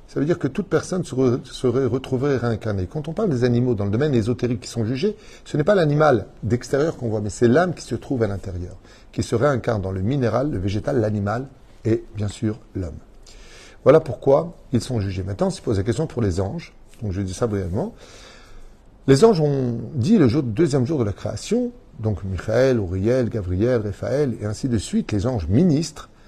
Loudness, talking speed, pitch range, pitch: -22 LUFS, 205 wpm, 105-140 Hz, 120 Hz